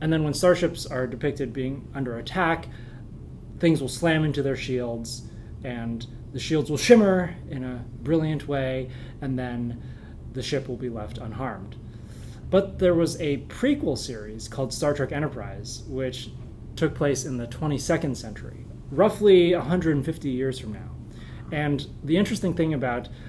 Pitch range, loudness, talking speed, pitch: 120-155 Hz, -25 LUFS, 150 wpm, 130 Hz